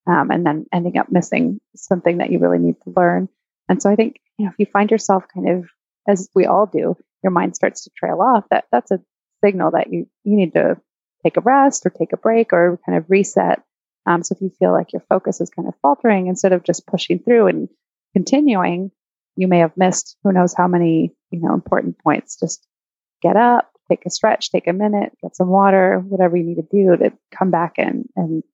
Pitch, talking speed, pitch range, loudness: 185 Hz, 225 wpm, 175-205 Hz, -17 LUFS